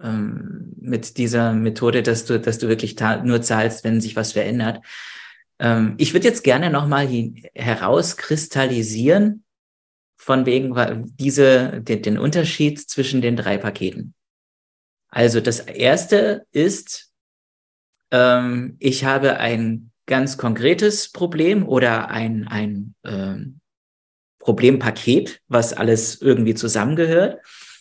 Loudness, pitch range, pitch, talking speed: -19 LUFS, 110-135 Hz, 120 Hz, 115 wpm